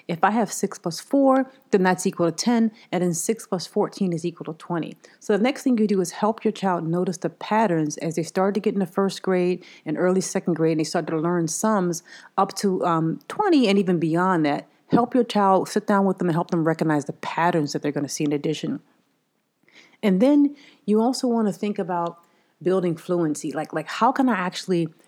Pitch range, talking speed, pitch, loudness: 170-215 Hz, 225 wpm, 185 Hz, -23 LUFS